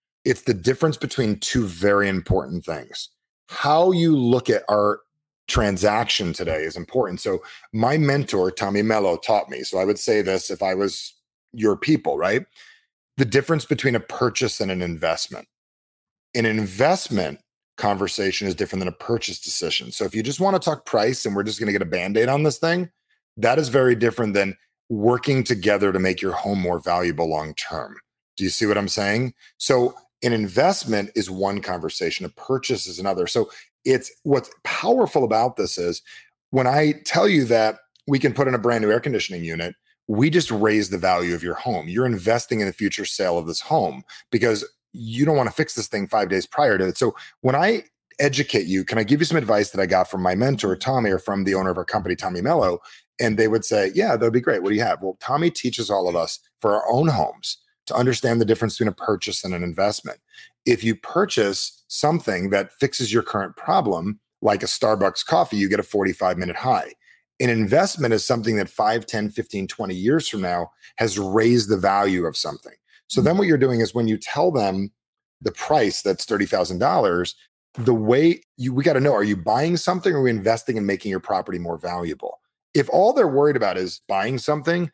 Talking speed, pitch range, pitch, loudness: 205 wpm, 100-130 Hz, 110 Hz, -21 LUFS